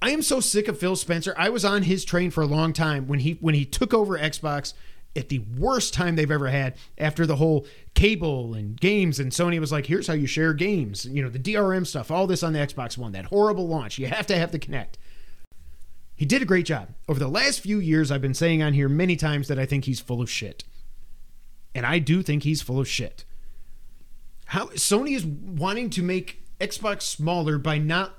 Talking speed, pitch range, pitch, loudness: 230 wpm, 140-185 Hz, 155 Hz, -24 LUFS